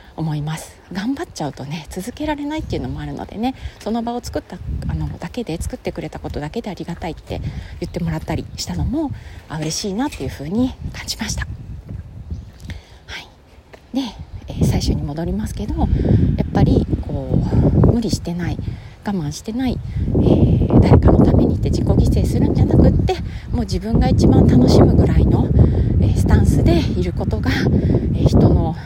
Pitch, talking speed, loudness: 155 Hz, 365 characters per minute, -18 LUFS